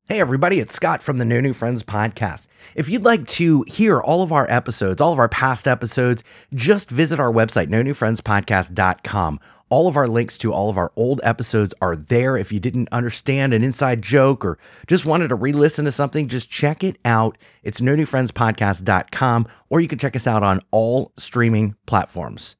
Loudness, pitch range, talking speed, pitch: -19 LUFS, 110-140 Hz, 195 wpm, 120 Hz